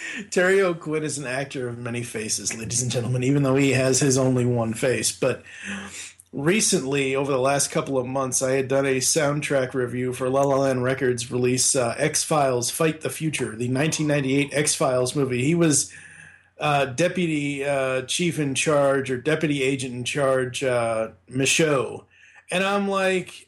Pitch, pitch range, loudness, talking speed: 135 Hz, 125-150 Hz, -22 LUFS, 175 wpm